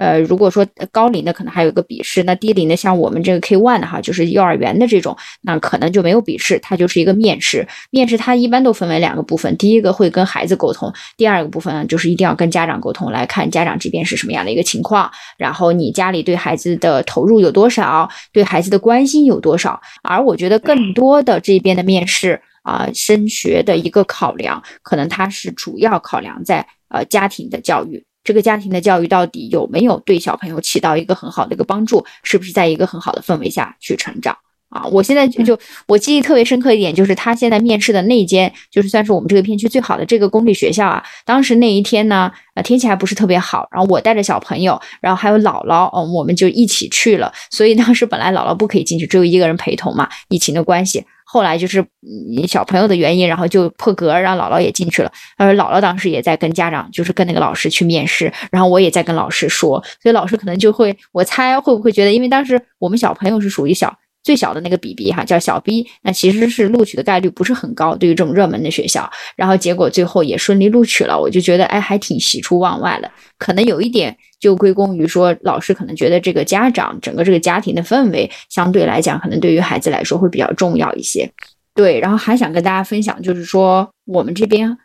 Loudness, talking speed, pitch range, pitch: -14 LUFS, 365 characters per minute, 180-225 Hz, 195 Hz